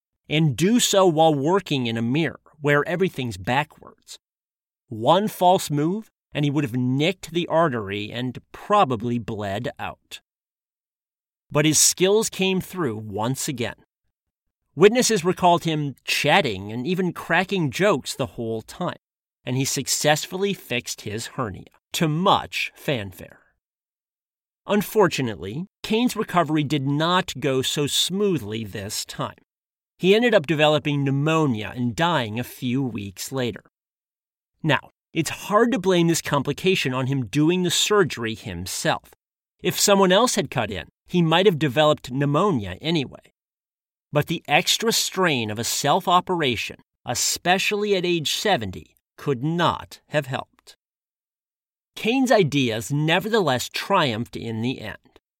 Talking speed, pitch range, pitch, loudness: 130 wpm, 125-185 Hz, 150 Hz, -22 LUFS